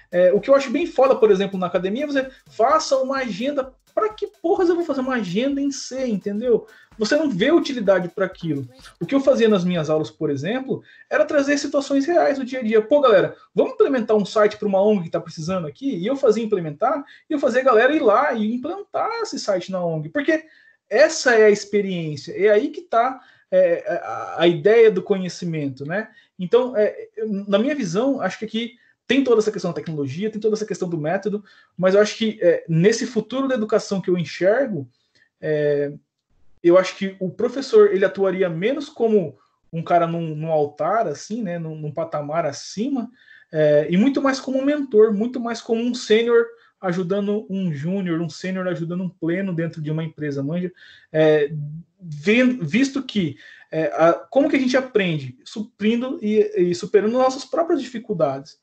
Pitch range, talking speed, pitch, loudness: 175-260 Hz, 195 wpm, 210 Hz, -20 LUFS